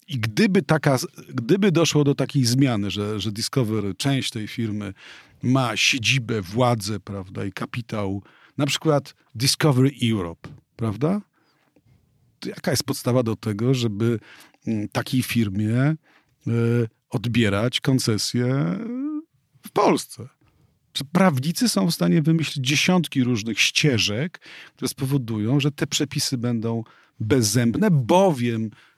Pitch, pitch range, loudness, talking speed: 130 Hz, 110-150 Hz, -22 LUFS, 115 wpm